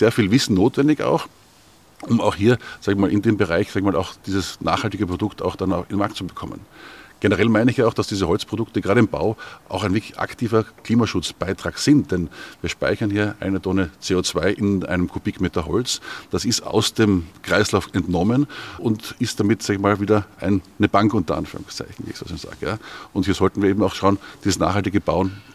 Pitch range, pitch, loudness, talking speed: 95-110 Hz, 100 Hz, -21 LUFS, 210 wpm